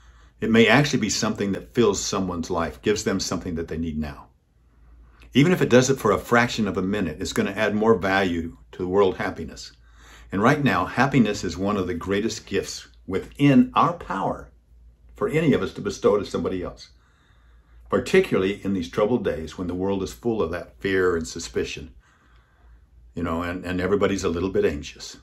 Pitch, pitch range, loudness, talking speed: 85 Hz, 65-100 Hz, -23 LUFS, 195 wpm